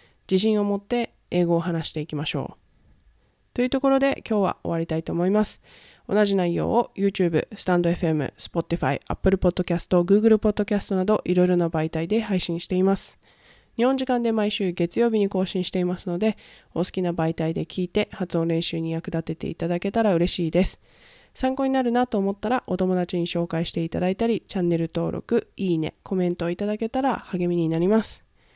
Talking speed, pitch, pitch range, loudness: 435 characters per minute, 185 Hz, 170-210 Hz, -24 LUFS